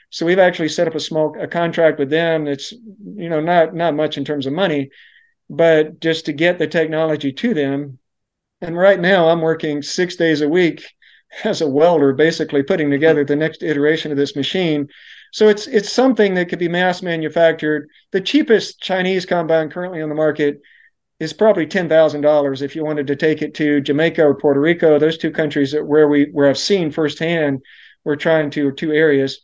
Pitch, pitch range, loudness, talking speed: 160 Hz, 150-175 Hz, -16 LUFS, 200 wpm